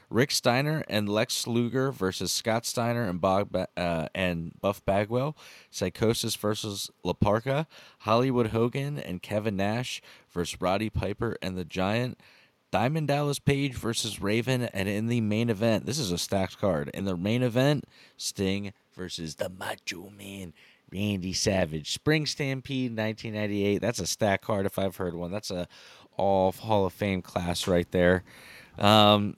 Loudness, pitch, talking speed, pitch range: -28 LUFS, 105 Hz, 155 wpm, 95-120 Hz